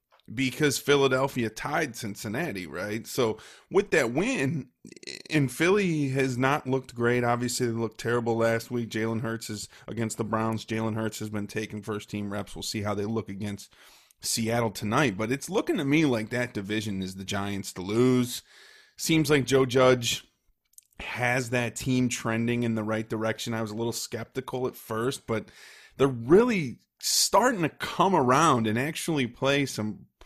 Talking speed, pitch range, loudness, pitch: 170 wpm, 110-130 Hz, -27 LUFS, 120 Hz